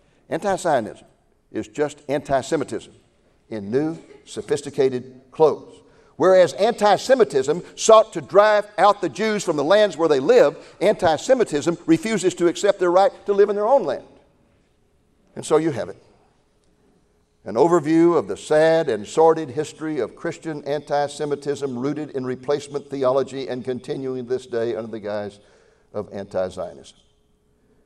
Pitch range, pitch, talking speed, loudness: 135-195 Hz, 155 Hz, 150 wpm, -20 LUFS